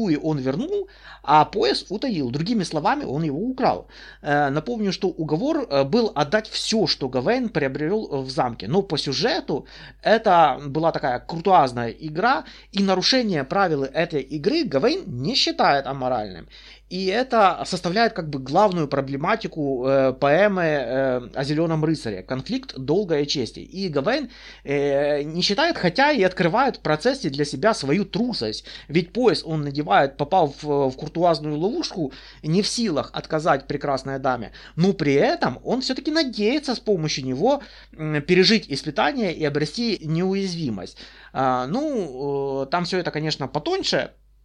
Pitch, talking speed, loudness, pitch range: 155 Hz, 145 wpm, -22 LUFS, 140-205 Hz